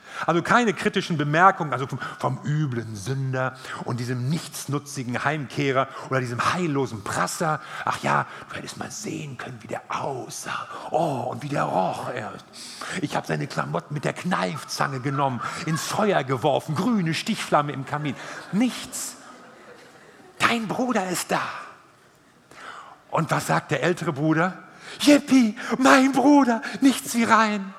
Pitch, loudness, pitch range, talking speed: 160 Hz, -24 LUFS, 135-215 Hz, 140 wpm